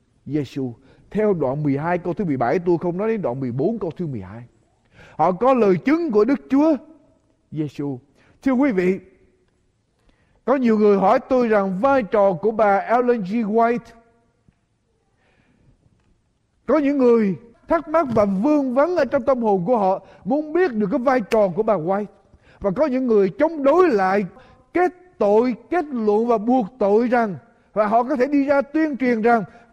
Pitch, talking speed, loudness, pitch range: 220 Hz, 180 wpm, -20 LUFS, 190-265 Hz